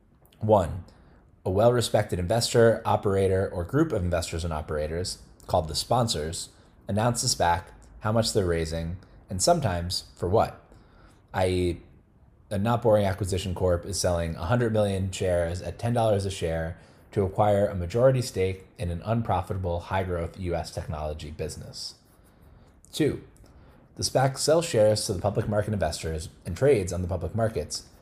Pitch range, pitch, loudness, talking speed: 85-110 Hz, 95 Hz, -26 LUFS, 150 wpm